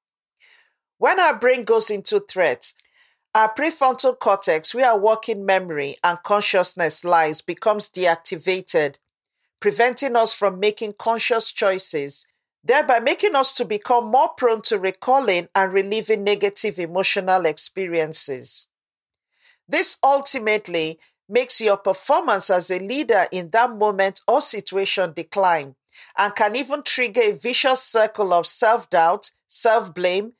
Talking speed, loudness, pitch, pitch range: 120 wpm, -19 LUFS, 215 Hz, 190-250 Hz